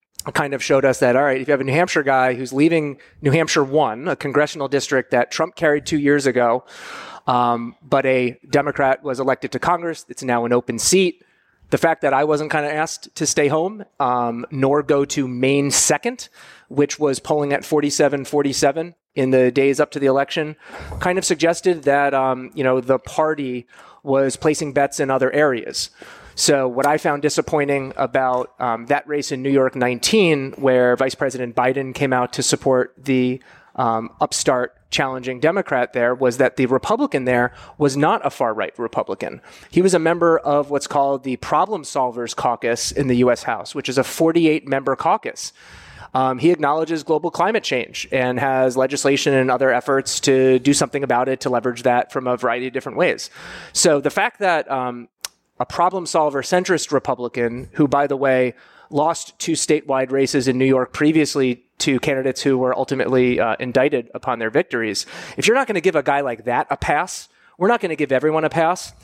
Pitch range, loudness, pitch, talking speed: 130-150 Hz, -19 LUFS, 140 Hz, 195 wpm